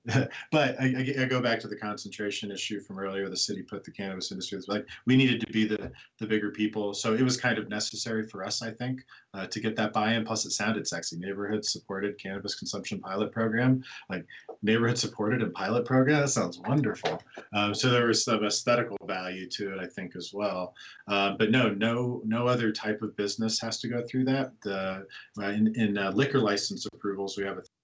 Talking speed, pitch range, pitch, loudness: 220 wpm, 100-120 Hz, 110 Hz, -29 LUFS